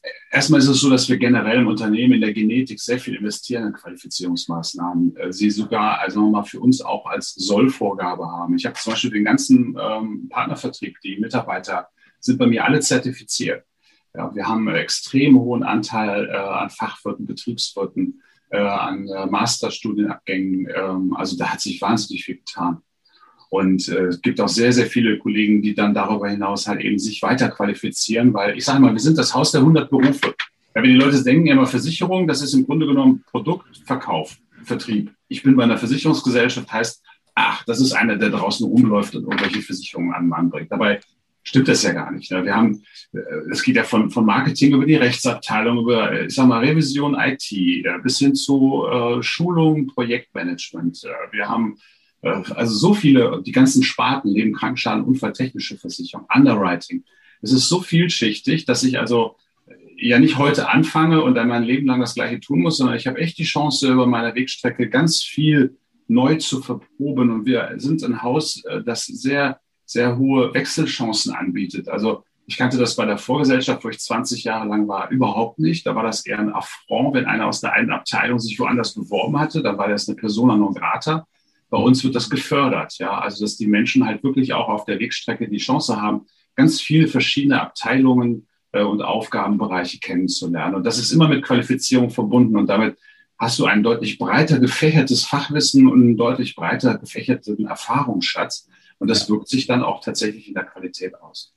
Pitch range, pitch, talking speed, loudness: 110-150 Hz, 130 Hz, 185 wpm, -19 LUFS